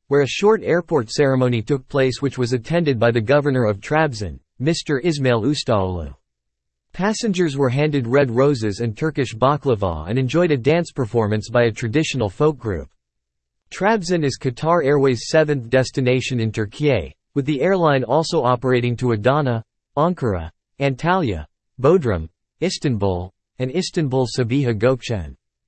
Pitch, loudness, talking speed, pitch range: 130 Hz, -19 LUFS, 140 wpm, 110-150 Hz